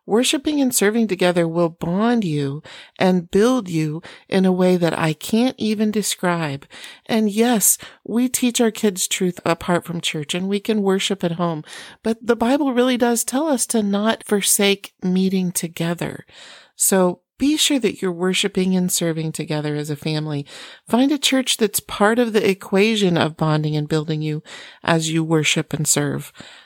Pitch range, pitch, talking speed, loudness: 165-225 Hz, 190 Hz, 170 wpm, -19 LUFS